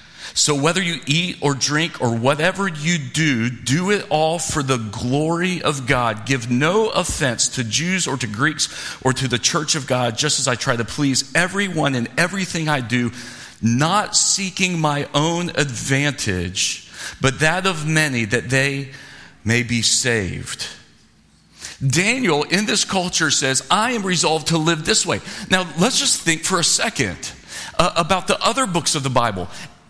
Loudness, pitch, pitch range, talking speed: -19 LUFS, 150 Hz, 125-175 Hz, 165 wpm